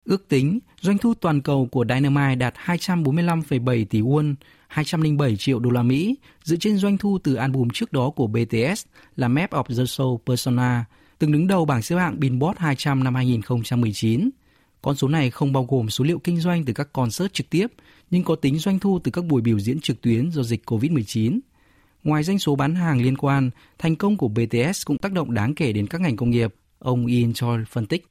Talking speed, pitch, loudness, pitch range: 210 wpm, 140 Hz, -22 LUFS, 125-165 Hz